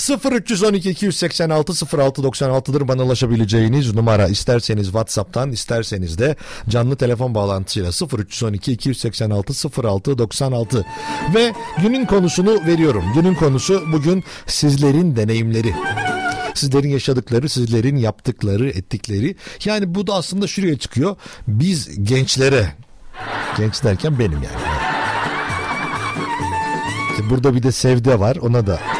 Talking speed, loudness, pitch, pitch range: 105 wpm, -18 LUFS, 130 Hz, 115-165 Hz